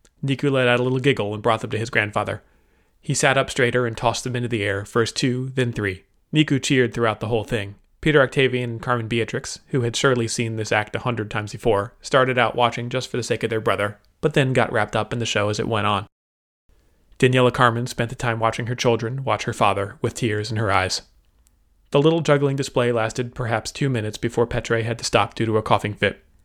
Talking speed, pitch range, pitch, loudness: 235 wpm, 105-125 Hz, 115 Hz, -21 LUFS